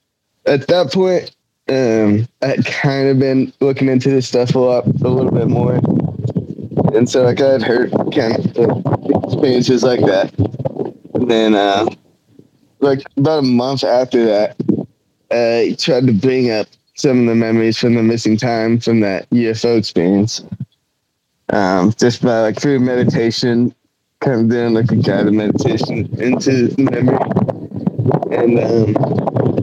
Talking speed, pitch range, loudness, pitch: 155 wpm, 115-135 Hz, -15 LUFS, 125 Hz